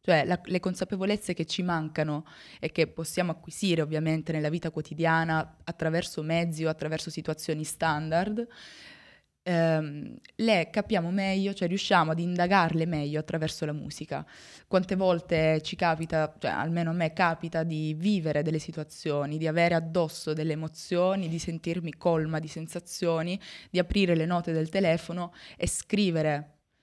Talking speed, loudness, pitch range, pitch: 145 wpm, -29 LUFS, 155-180 Hz, 165 Hz